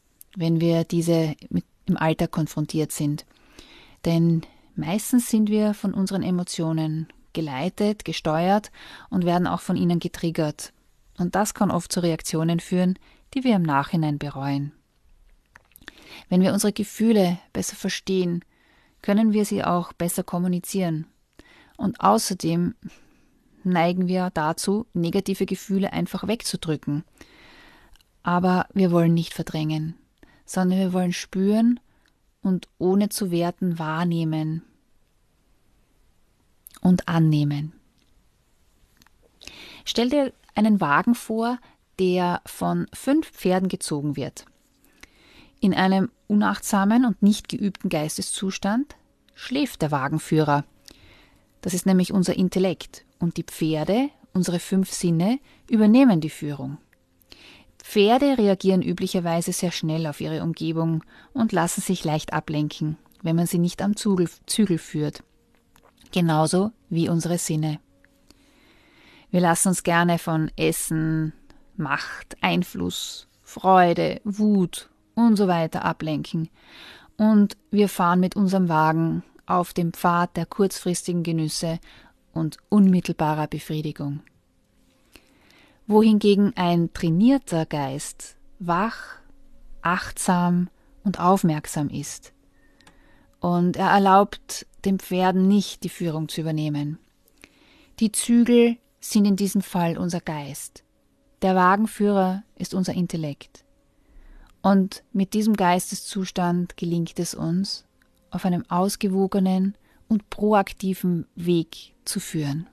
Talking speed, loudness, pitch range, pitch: 110 wpm, -23 LUFS, 165-200 Hz, 180 Hz